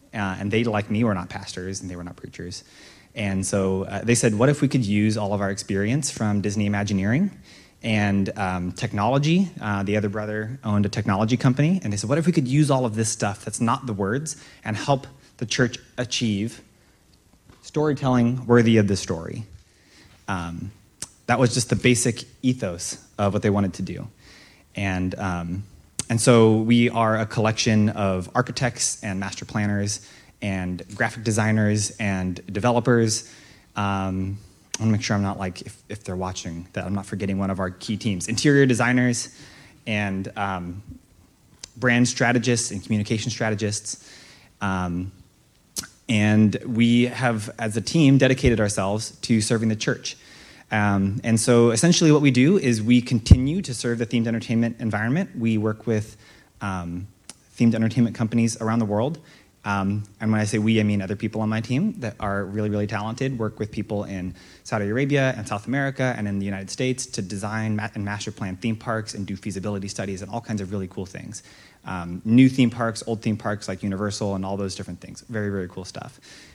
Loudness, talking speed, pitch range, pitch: -23 LUFS, 185 wpm, 100-120 Hz, 110 Hz